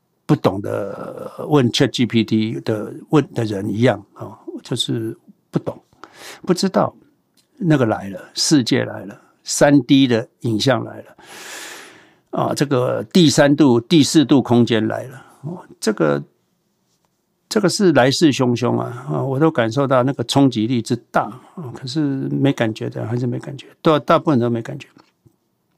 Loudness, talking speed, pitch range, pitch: -18 LUFS, 225 characters per minute, 120-160 Hz, 135 Hz